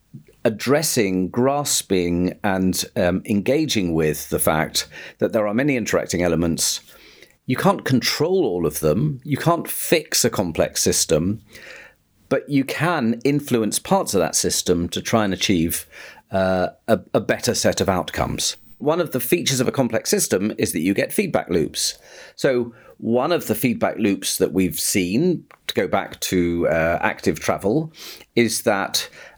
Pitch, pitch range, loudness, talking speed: 110 Hz, 90-135 Hz, -20 LUFS, 155 wpm